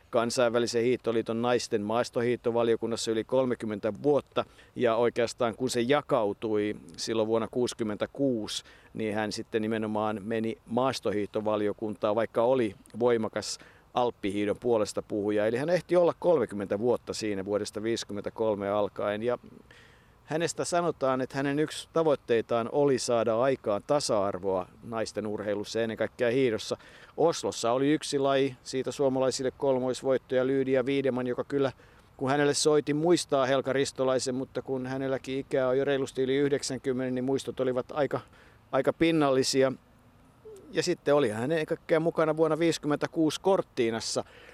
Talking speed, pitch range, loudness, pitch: 125 wpm, 110-140 Hz, -29 LUFS, 125 Hz